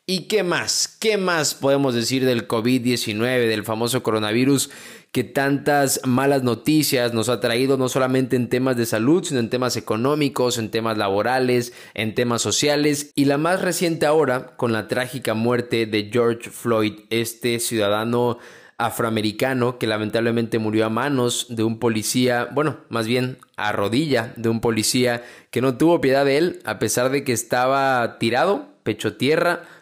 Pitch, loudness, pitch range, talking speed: 125 Hz, -21 LUFS, 115-135 Hz, 160 wpm